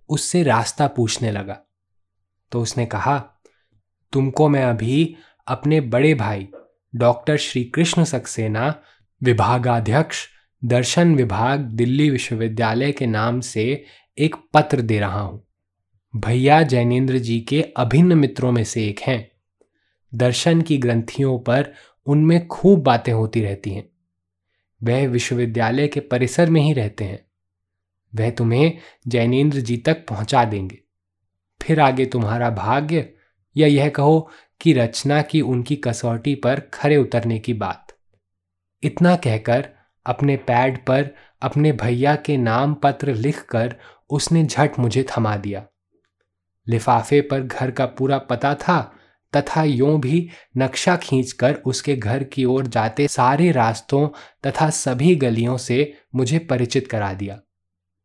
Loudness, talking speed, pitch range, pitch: -19 LUFS, 130 wpm, 110-145 Hz, 125 Hz